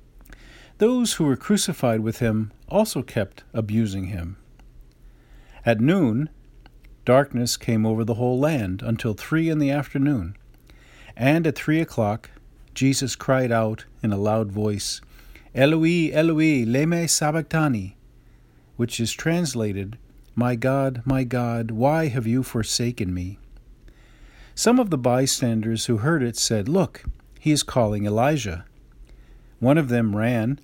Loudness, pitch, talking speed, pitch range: -22 LUFS, 120 Hz, 130 wpm, 110-145 Hz